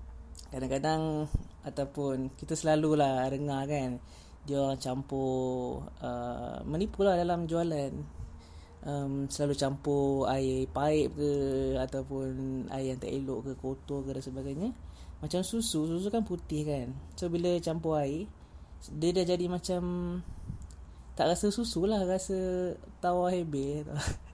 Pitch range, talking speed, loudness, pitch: 130-170 Hz, 125 wpm, -32 LUFS, 140 Hz